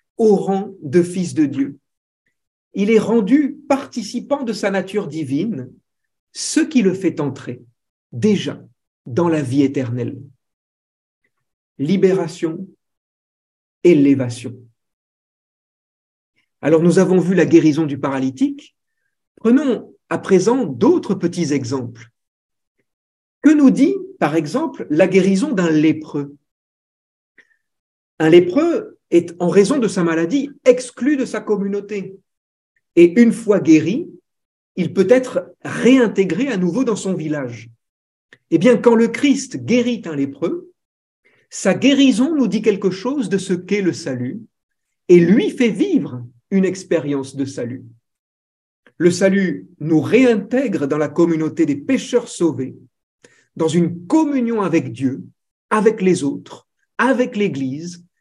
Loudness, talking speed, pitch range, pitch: -17 LUFS, 125 wpm, 150-245 Hz, 190 Hz